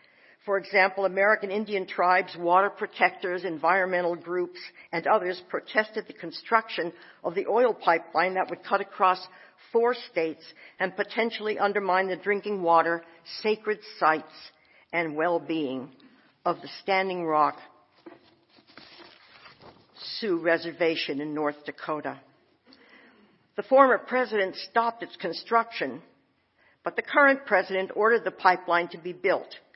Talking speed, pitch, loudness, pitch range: 120 wpm, 185 Hz, -26 LUFS, 170-215 Hz